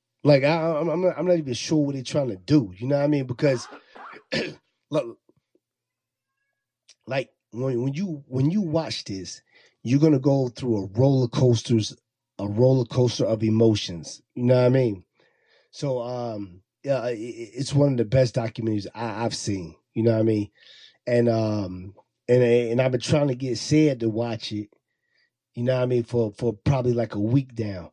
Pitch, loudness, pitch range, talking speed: 125 Hz, -24 LUFS, 110-140 Hz, 190 wpm